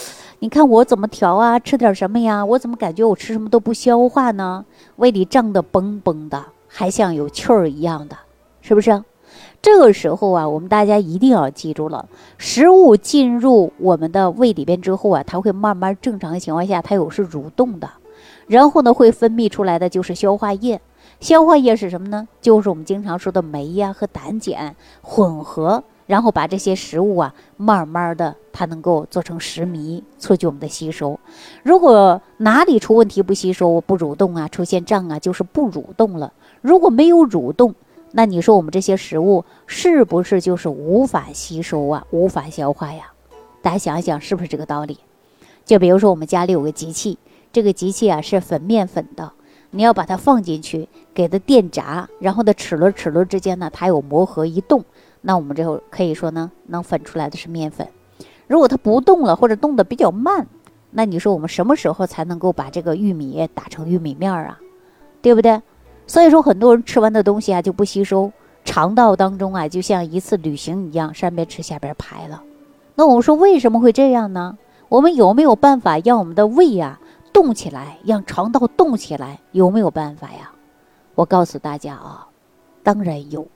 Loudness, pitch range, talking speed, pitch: -16 LUFS, 170-230 Hz, 290 characters per minute, 195 Hz